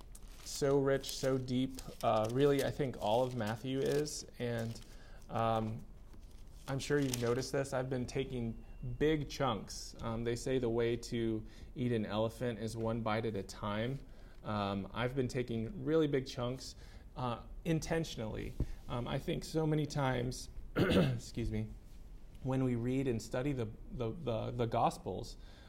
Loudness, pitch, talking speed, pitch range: -37 LUFS, 120 Hz, 155 wpm, 110-135 Hz